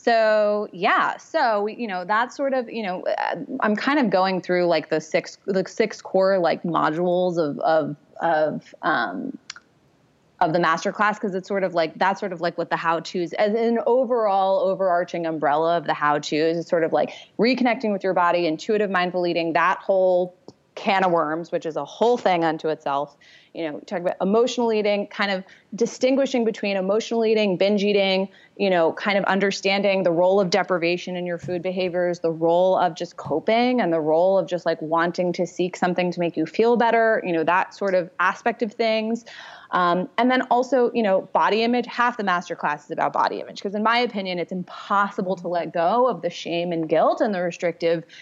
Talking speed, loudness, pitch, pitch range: 205 wpm, -22 LUFS, 185 Hz, 170-215 Hz